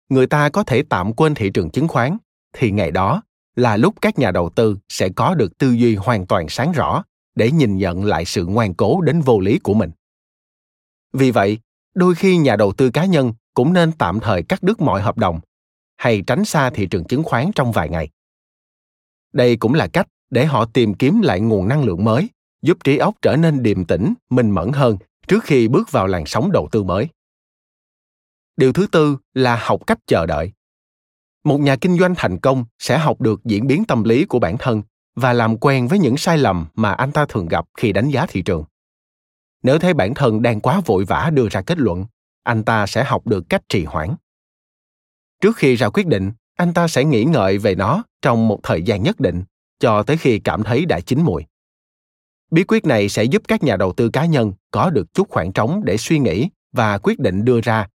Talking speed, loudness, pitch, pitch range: 220 wpm, -17 LUFS, 120 Hz, 100-150 Hz